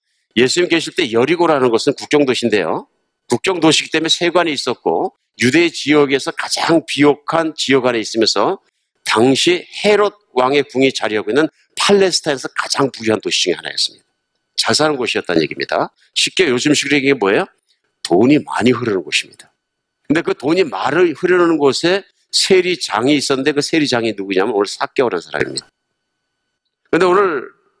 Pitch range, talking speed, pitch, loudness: 135-180 Hz, 365 characters per minute, 150 Hz, -15 LUFS